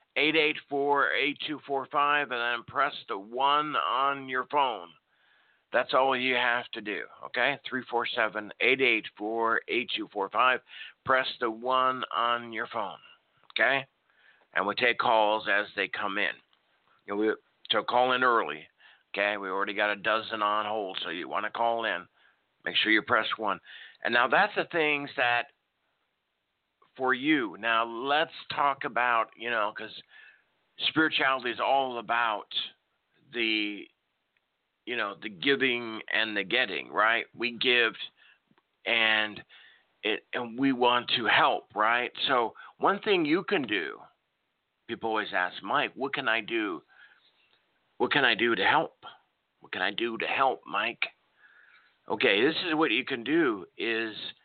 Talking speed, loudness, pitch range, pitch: 160 wpm, -27 LUFS, 115-145 Hz, 125 Hz